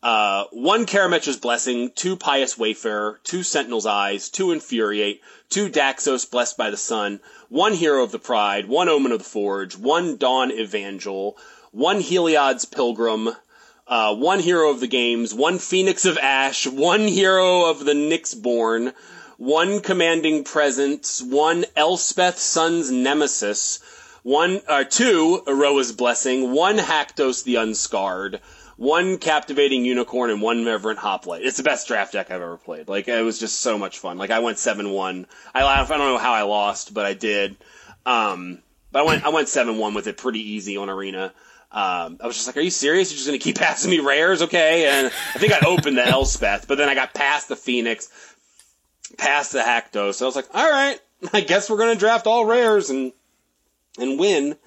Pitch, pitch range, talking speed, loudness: 135 Hz, 115-170 Hz, 180 wpm, -20 LUFS